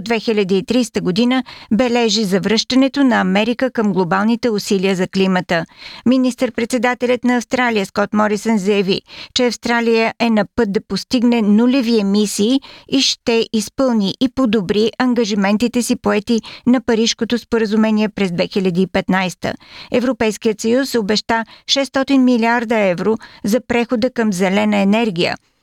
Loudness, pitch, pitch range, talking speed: -16 LUFS, 230 Hz, 205-245 Hz, 115 wpm